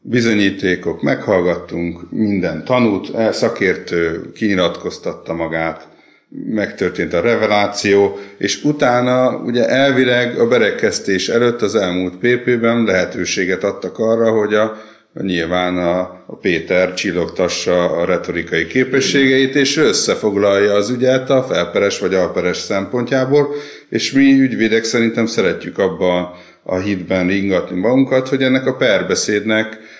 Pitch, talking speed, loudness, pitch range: 110 Hz, 115 wpm, -16 LUFS, 95-125 Hz